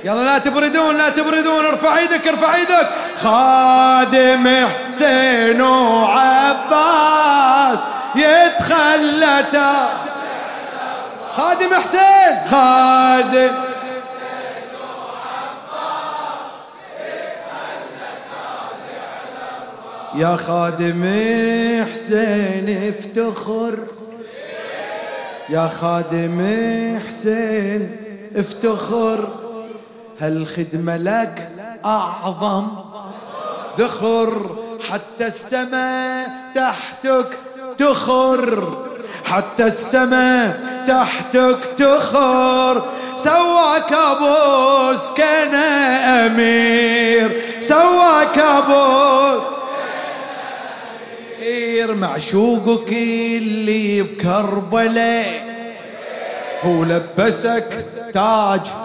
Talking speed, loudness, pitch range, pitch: 50 wpm, -15 LUFS, 225-275 Hz, 250 Hz